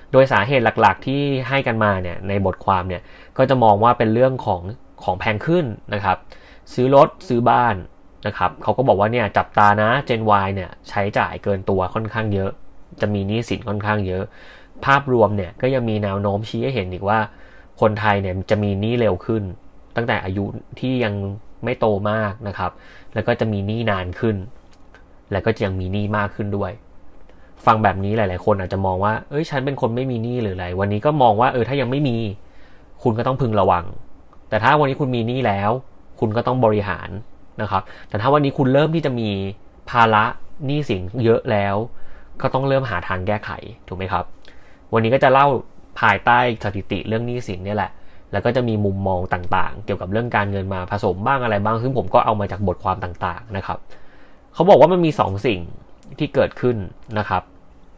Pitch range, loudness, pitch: 95-120 Hz, -20 LUFS, 105 Hz